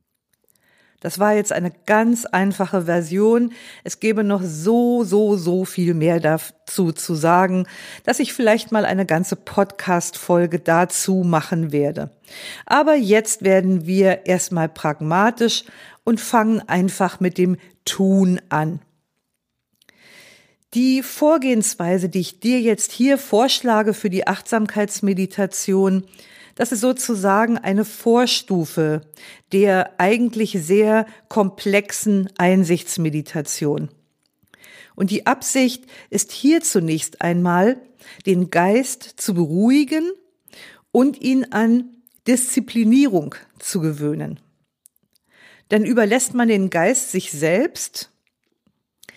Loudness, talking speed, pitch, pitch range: -19 LUFS, 105 wpm, 200 Hz, 180-230 Hz